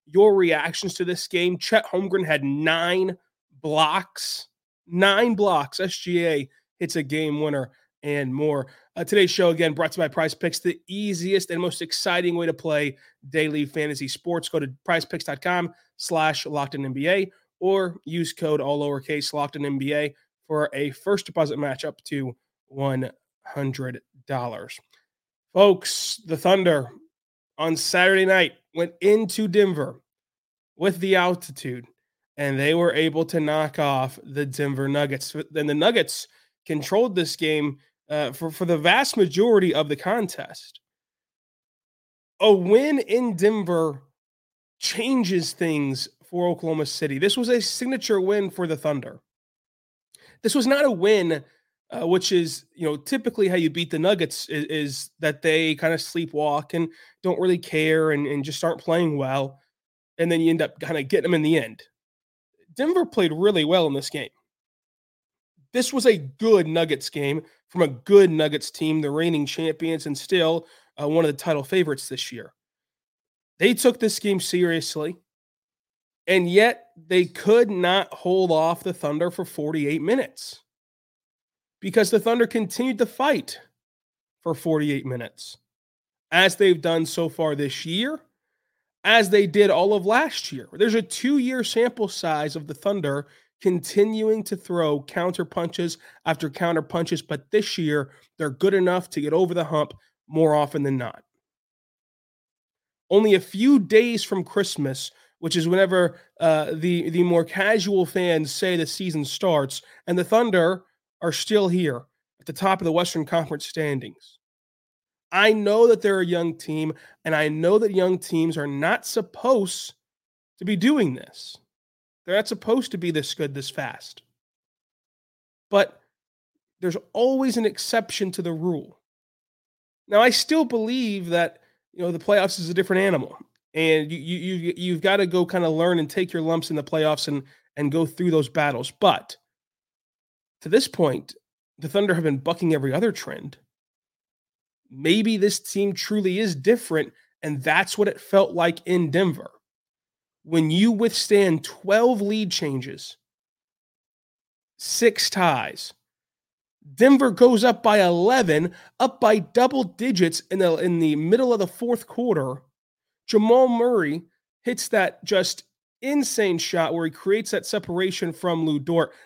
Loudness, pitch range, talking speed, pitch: -22 LUFS, 155-200 Hz, 155 wpm, 170 Hz